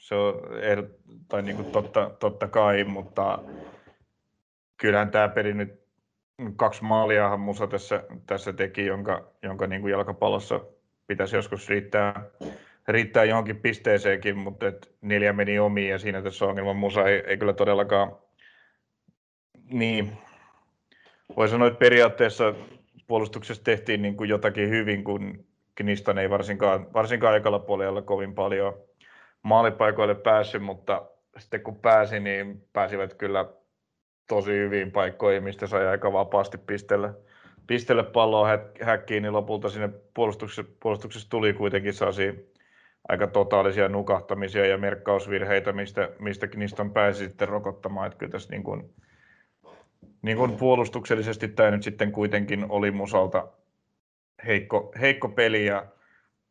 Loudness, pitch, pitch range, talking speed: -25 LUFS, 100 Hz, 100-110 Hz, 125 wpm